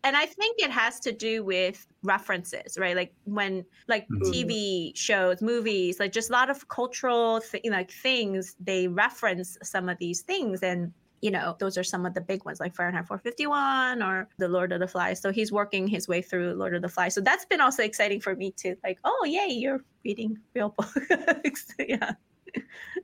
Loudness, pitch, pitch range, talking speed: -28 LUFS, 200 Hz, 185-240 Hz, 200 wpm